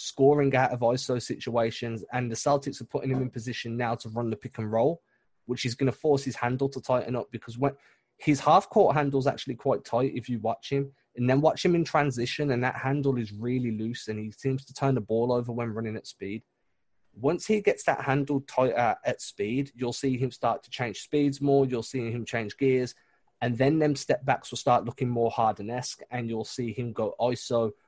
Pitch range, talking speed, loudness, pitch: 115-135 Hz, 230 wpm, -28 LUFS, 125 Hz